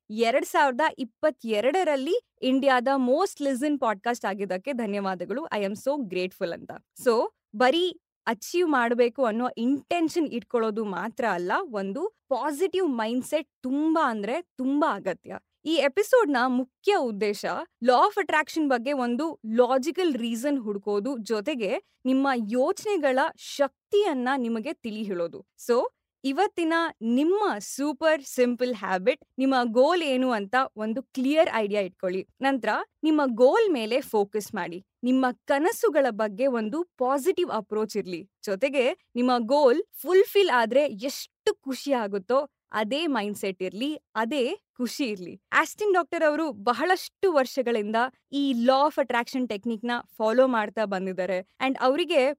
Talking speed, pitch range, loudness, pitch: 125 wpm, 225-305 Hz, -26 LUFS, 260 Hz